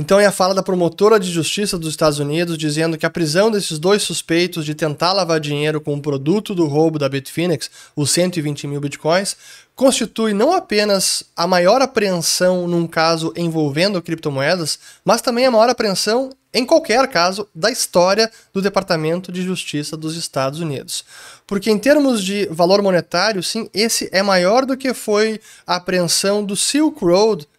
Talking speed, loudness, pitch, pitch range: 170 wpm, -17 LUFS, 180 Hz, 160-210 Hz